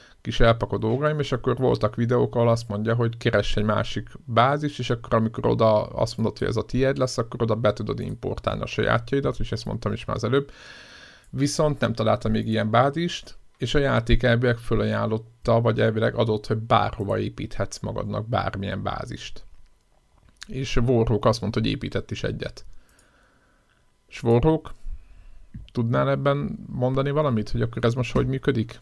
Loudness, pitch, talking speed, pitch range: -24 LUFS, 115 Hz, 165 wpm, 110-130 Hz